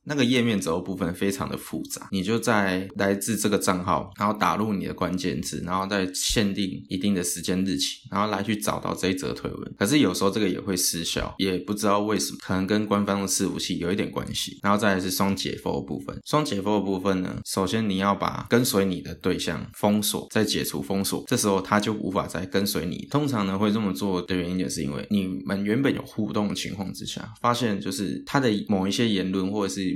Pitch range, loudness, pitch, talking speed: 95-105 Hz, -25 LUFS, 100 Hz, 345 characters per minute